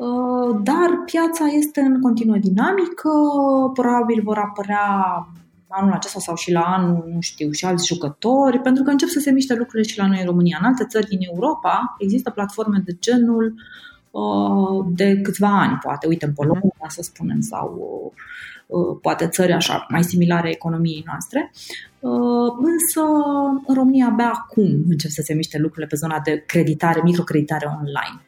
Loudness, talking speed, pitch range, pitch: -19 LUFS, 160 wpm, 170-260 Hz, 205 Hz